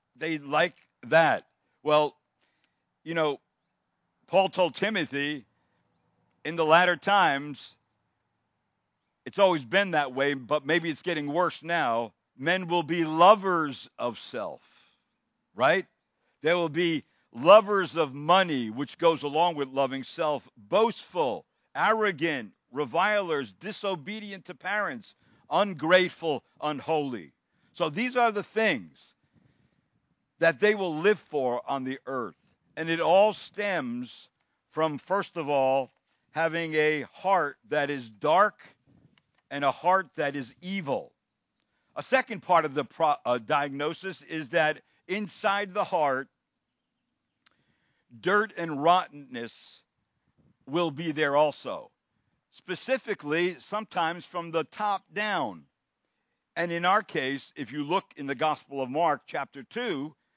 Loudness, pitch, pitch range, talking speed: -27 LUFS, 160 Hz, 145-190 Hz, 125 wpm